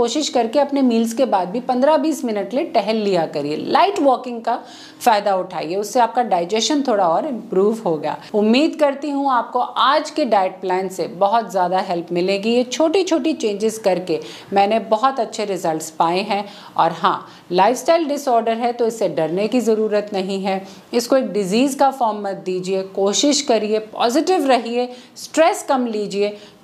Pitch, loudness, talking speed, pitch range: 220 Hz, -19 LUFS, 170 wpm, 190-260 Hz